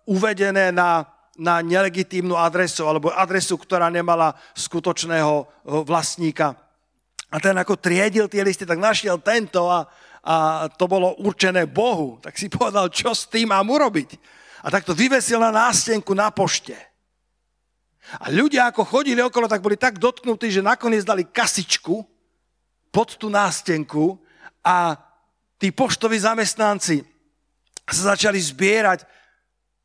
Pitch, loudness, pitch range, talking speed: 190 Hz, -20 LUFS, 170-220 Hz, 130 wpm